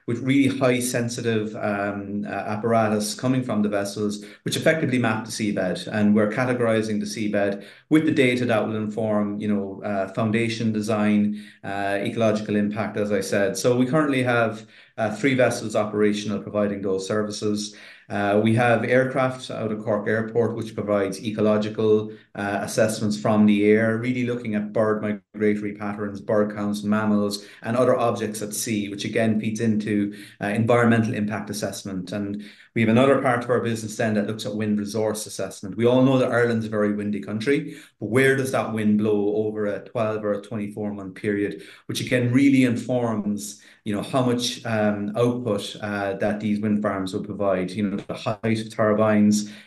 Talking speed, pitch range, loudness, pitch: 180 wpm, 105-115 Hz, -23 LUFS, 105 Hz